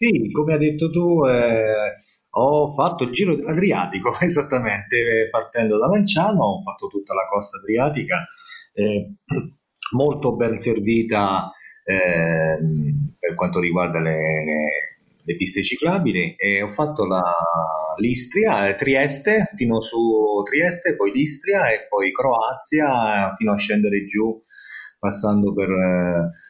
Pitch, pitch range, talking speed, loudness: 110 Hz, 95-150 Hz, 125 wpm, -20 LUFS